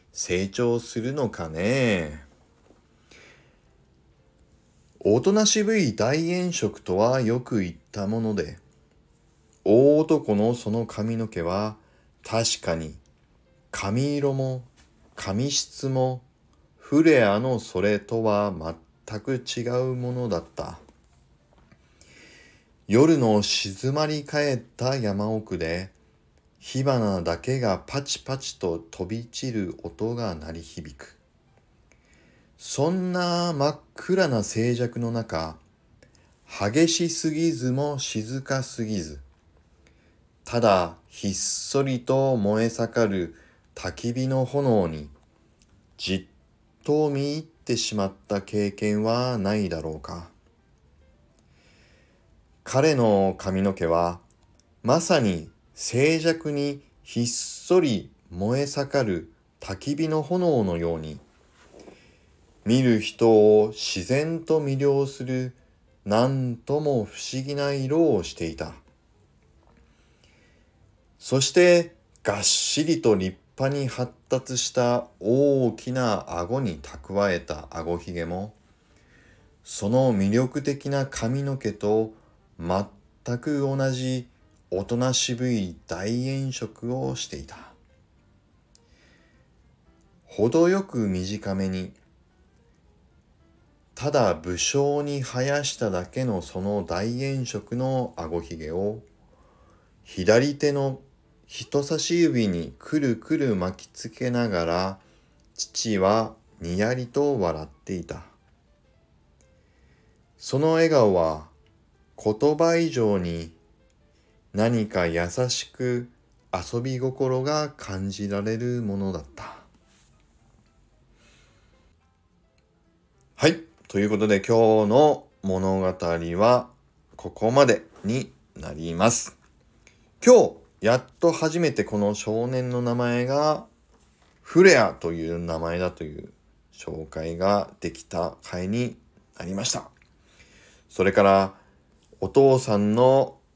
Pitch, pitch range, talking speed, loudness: 110 Hz, 85-130 Hz, 175 characters per minute, -24 LUFS